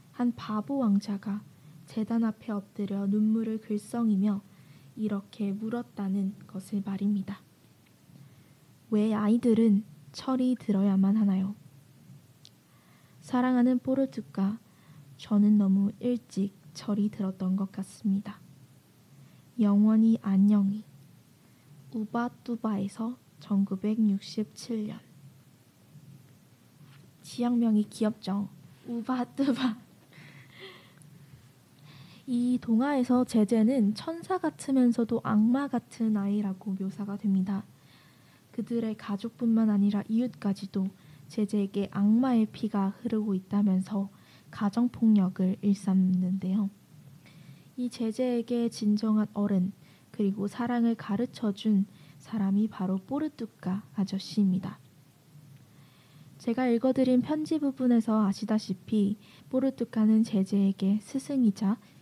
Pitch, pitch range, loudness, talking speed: 205 Hz, 190-230 Hz, -29 LUFS, 225 characters per minute